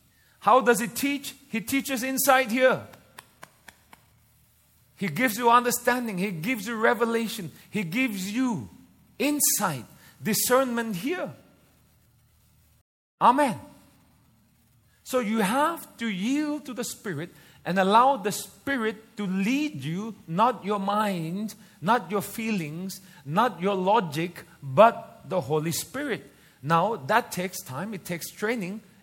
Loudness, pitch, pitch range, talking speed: -26 LUFS, 210 Hz, 185-245 Hz, 120 wpm